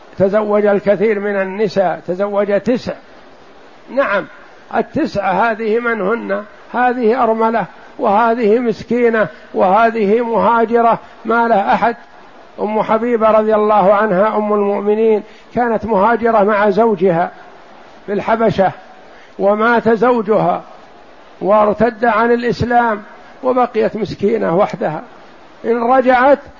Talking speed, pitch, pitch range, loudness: 95 wpm, 220 Hz, 205-230 Hz, -14 LUFS